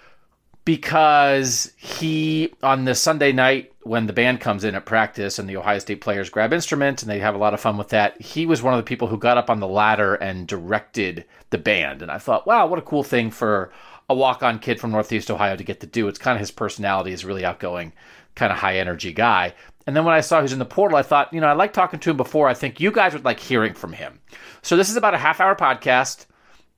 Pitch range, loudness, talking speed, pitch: 105-145 Hz, -20 LUFS, 255 wpm, 120 Hz